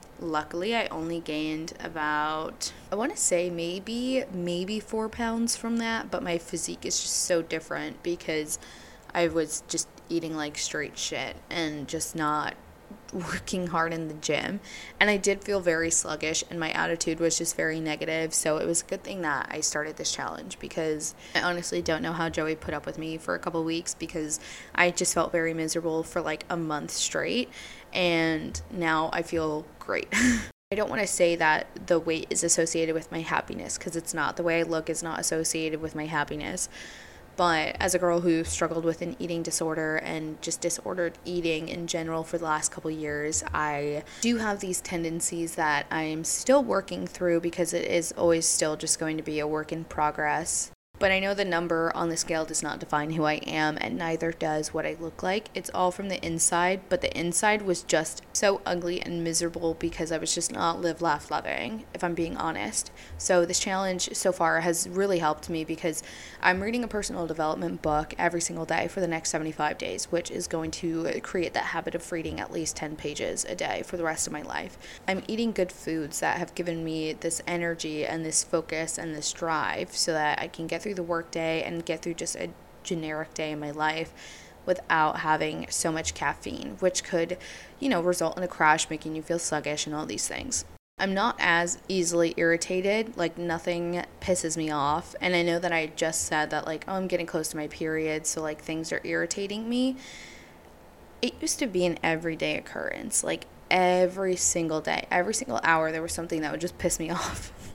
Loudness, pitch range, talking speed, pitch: -28 LUFS, 160-175 Hz, 205 wpm, 165 Hz